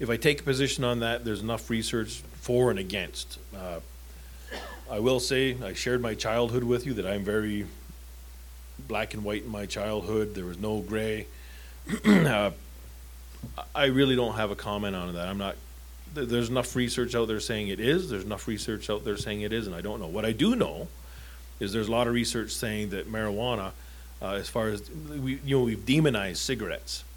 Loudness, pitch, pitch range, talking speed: -29 LUFS, 105 Hz, 85-120 Hz, 200 wpm